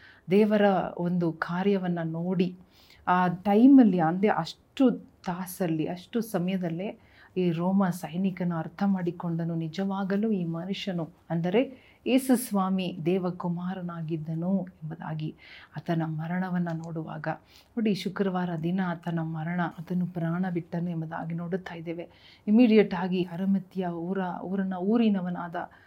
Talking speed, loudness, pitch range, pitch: 100 wpm, -28 LUFS, 170-195 Hz, 180 Hz